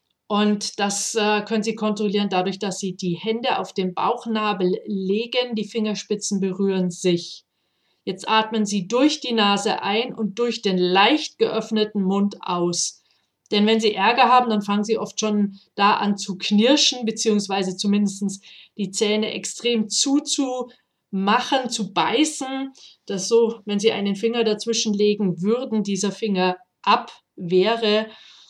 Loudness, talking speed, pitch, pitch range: -21 LUFS, 140 wpm, 210 Hz, 200-225 Hz